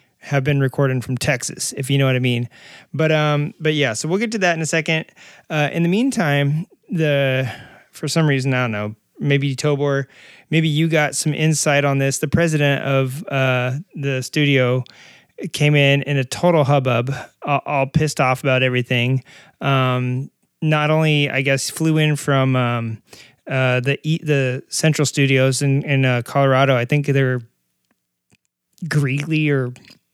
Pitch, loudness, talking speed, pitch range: 140 Hz, -18 LUFS, 170 wpm, 130-155 Hz